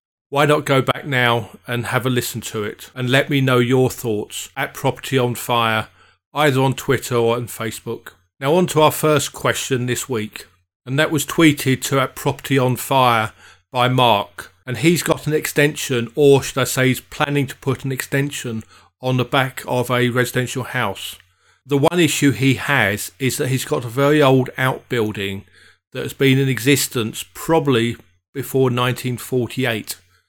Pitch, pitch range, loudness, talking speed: 130 Hz, 120-140 Hz, -18 LUFS, 180 wpm